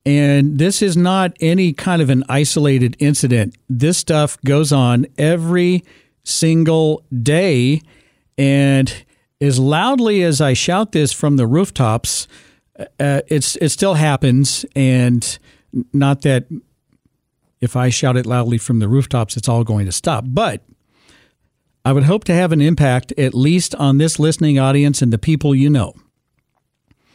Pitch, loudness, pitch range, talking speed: 140 Hz, -15 LUFS, 125-160 Hz, 150 wpm